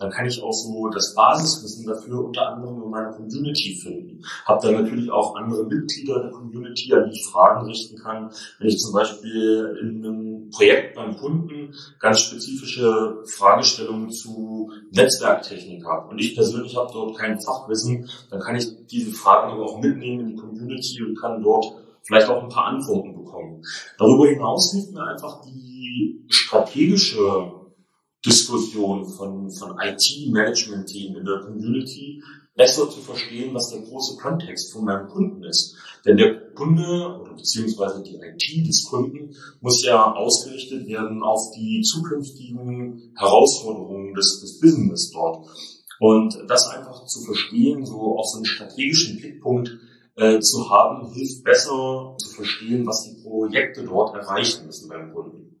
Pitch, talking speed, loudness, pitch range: 115 Hz, 155 wpm, -20 LUFS, 110-135 Hz